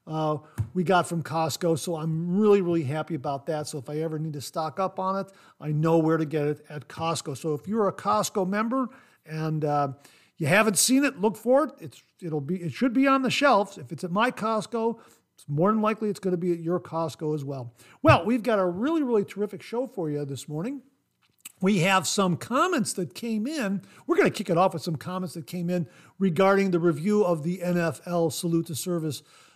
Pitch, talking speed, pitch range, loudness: 175 Hz, 225 wpm, 155-210 Hz, -26 LUFS